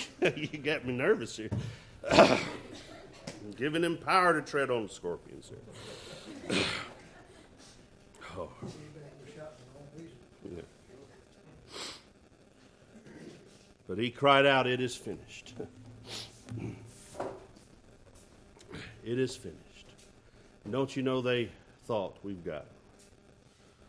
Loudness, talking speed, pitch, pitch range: -31 LUFS, 85 wpm, 125 Hz, 110-145 Hz